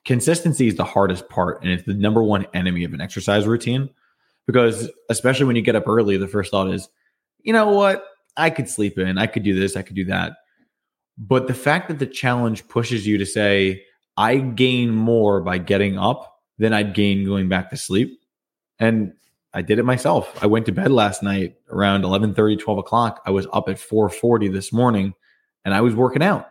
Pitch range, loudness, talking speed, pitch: 100-125 Hz, -20 LUFS, 210 wpm, 110 Hz